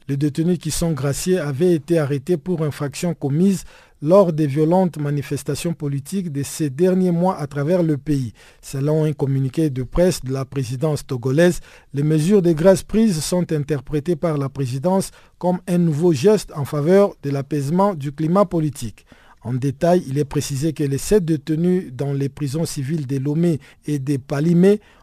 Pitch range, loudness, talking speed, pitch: 140-175 Hz, -20 LUFS, 175 wpm, 155 Hz